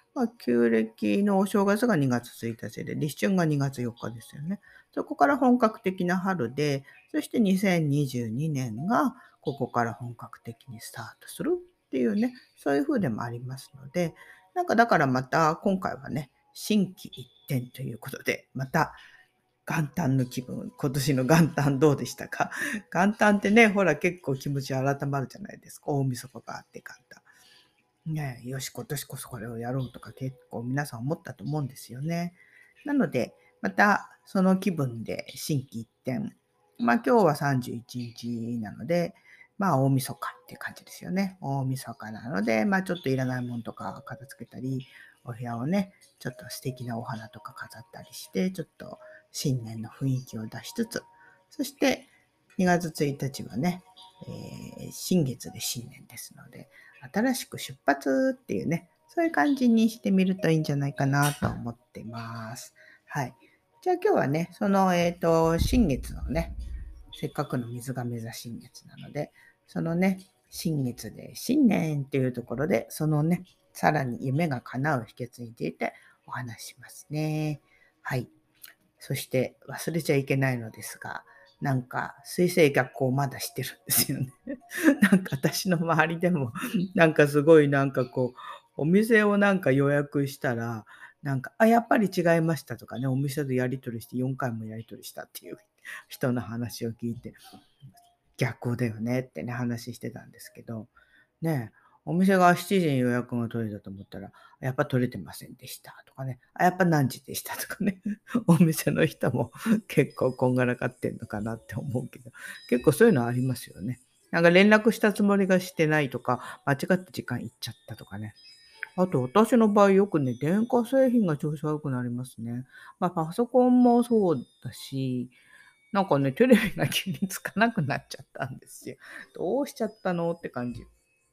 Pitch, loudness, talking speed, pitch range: 140 Hz, -27 LUFS, 320 characters per minute, 125-185 Hz